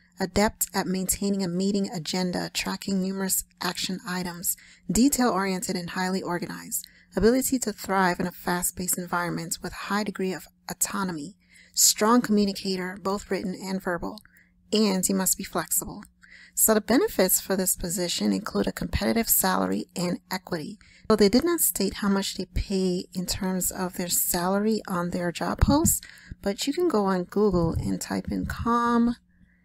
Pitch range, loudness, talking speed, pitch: 180-205 Hz, -25 LUFS, 160 wpm, 190 Hz